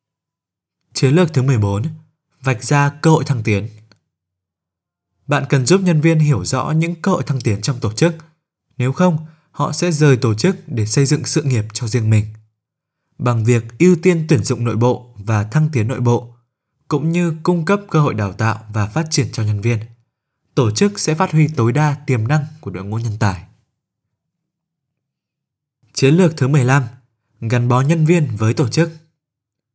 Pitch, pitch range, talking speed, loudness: 135 Hz, 115-155 Hz, 185 wpm, -16 LUFS